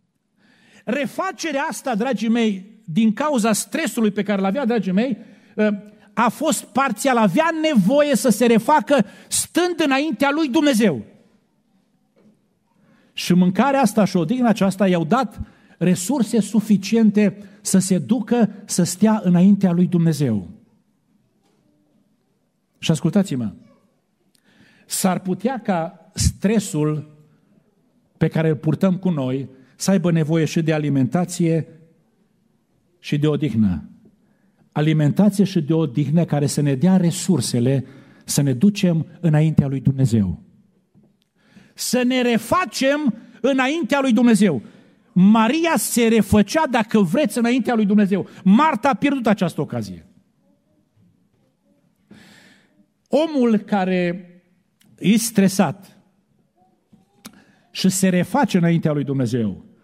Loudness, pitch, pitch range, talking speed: -19 LUFS, 205 Hz, 175-230 Hz, 105 wpm